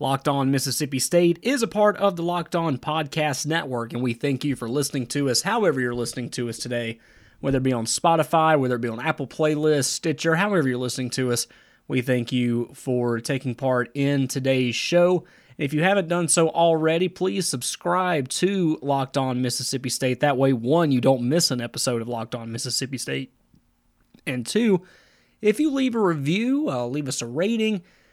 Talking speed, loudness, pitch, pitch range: 195 wpm, -23 LUFS, 140 Hz, 125-170 Hz